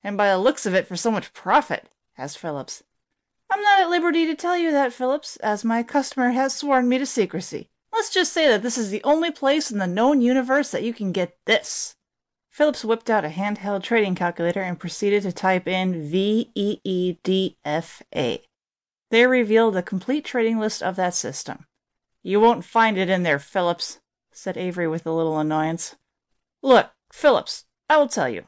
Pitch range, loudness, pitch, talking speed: 185-265 Hz, -22 LUFS, 215 Hz, 195 wpm